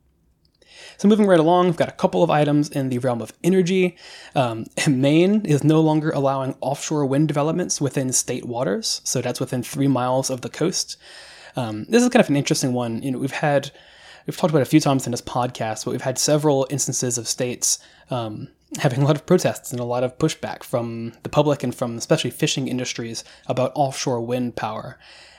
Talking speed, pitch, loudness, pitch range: 205 wpm, 140 Hz, -21 LUFS, 125-155 Hz